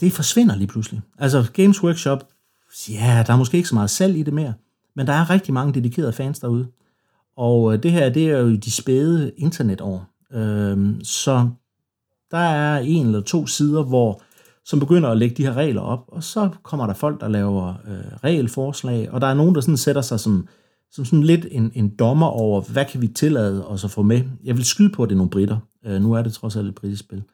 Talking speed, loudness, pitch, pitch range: 225 wpm, -19 LUFS, 125 Hz, 110-150 Hz